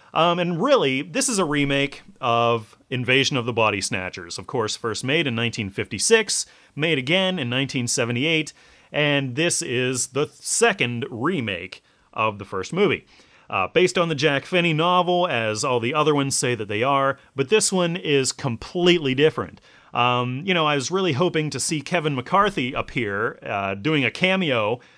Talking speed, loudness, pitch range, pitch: 170 wpm, -22 LUFS, 125-175 Hz, 140 Hz